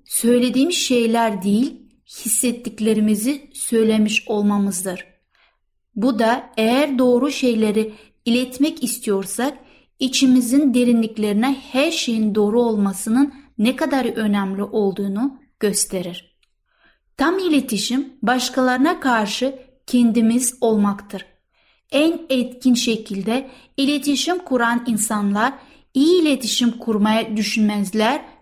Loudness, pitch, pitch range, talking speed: -19 LUFS, 240 Hz, 215-265 Hz, 85 wpm